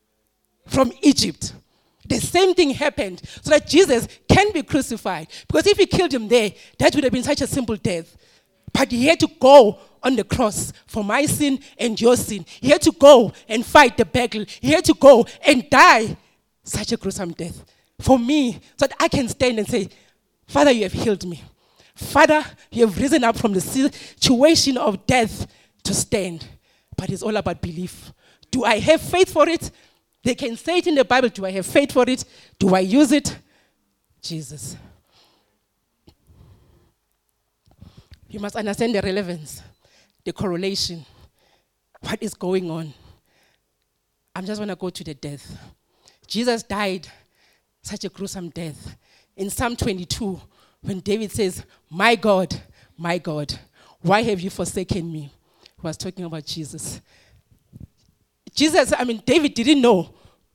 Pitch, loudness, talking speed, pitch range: 215 Hz, -19 LUFS, 165 wpm, 180-270 Hz